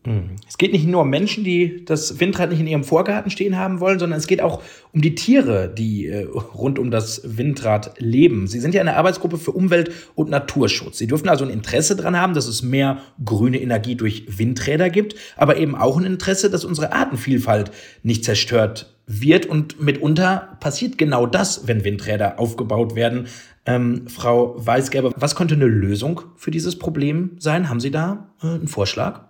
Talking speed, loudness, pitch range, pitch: 180 wpm, -19 LUFS, 115-175 Hz, 140 Hz